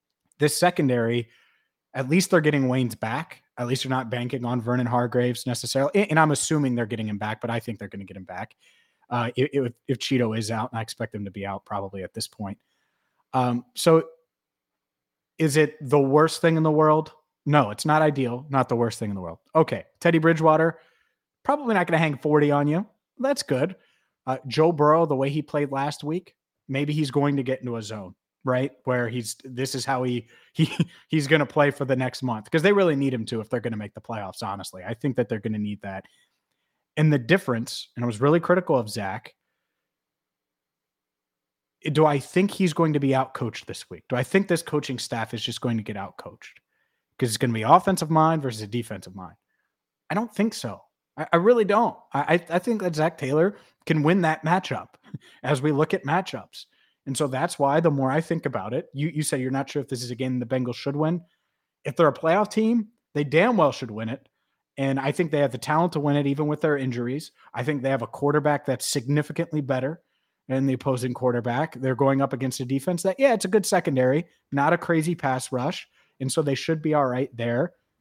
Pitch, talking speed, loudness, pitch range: 140 Hz, 225 wpm, -24 LUFS, 120-160 Hz